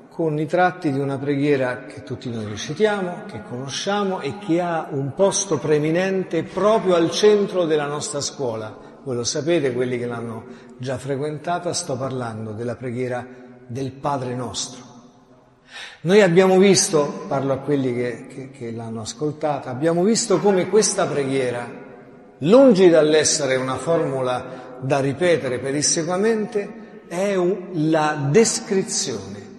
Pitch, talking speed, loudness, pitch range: 145 Hz, 130 wpm, -20 LUFS, 125-180 Hz